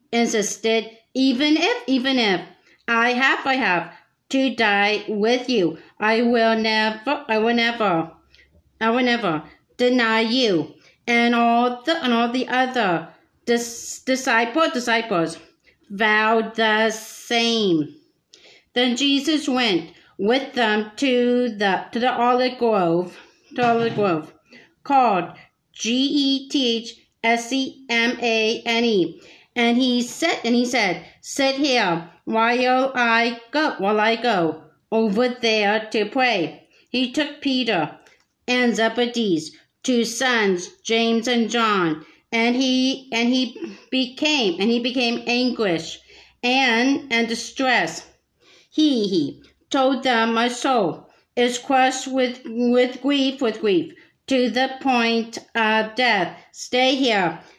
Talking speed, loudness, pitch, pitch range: 130 wpm, -20 LUFS, 235 Hz, 225-260 Hz